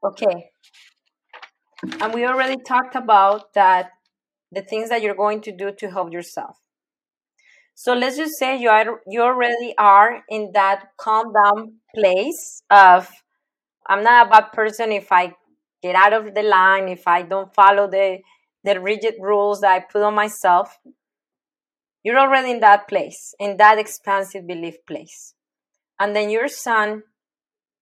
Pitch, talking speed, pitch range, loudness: 210 Hz, 155 wpm, 195-235 Hz, -17 LUFS